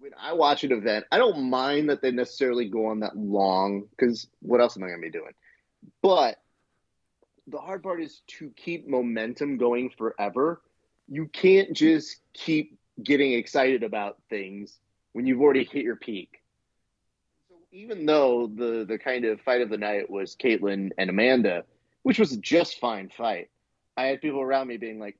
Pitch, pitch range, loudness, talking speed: 125 Hz, 110-150 Hz, -25 LUFS, 180 wpm